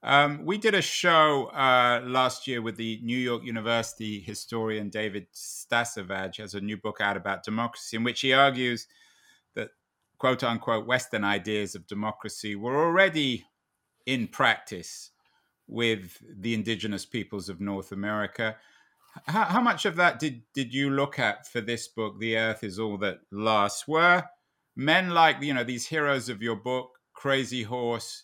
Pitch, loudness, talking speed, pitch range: 115 Hz, -27 LUFS, 160 wpm, 105-135 Hz